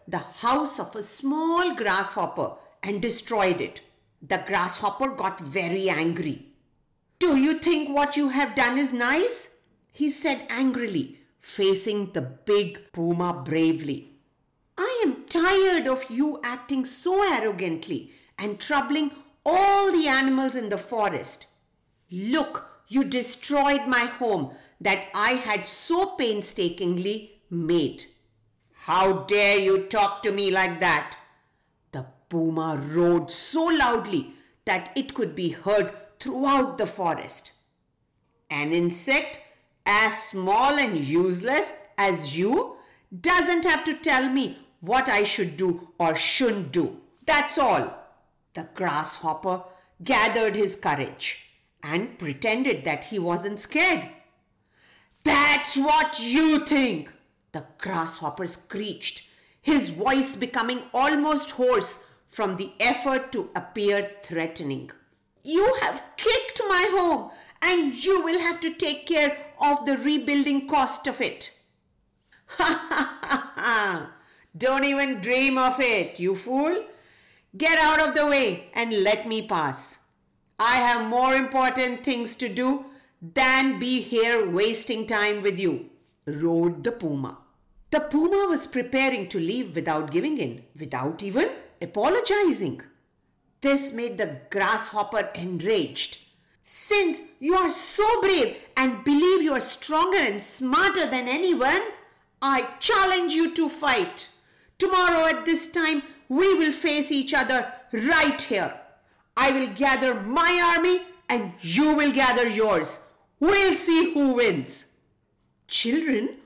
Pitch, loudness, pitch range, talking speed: 260 Hz, -24 LUFS, 200-310 Hz, 125 wpm